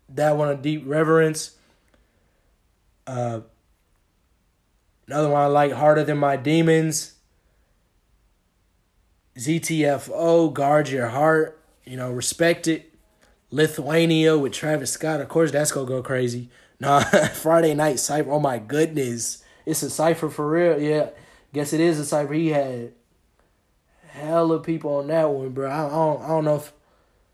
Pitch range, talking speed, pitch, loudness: 120-155 Hz, 145 wpm, 145 Hz, -22 LUFS